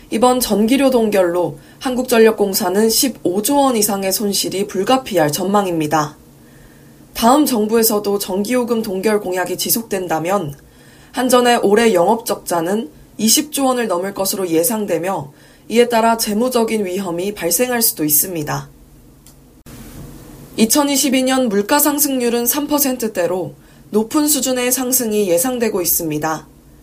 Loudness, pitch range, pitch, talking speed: -16 LUFS, 180-245 Hz, 210 Hz, 270 characters per minute